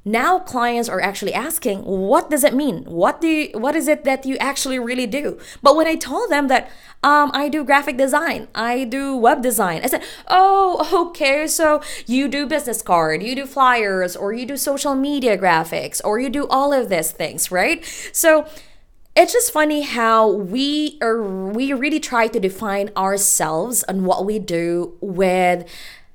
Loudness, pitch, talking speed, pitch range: -18 LUFS, 260 Hz, 180 wpm, 205-295 Hz